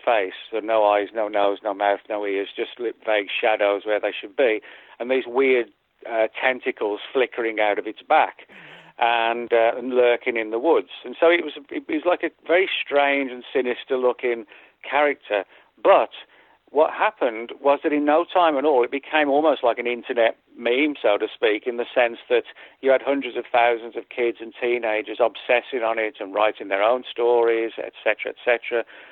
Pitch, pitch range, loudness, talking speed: 120 Hz, 110-140 Hz, -22 LUFS, 185 wpm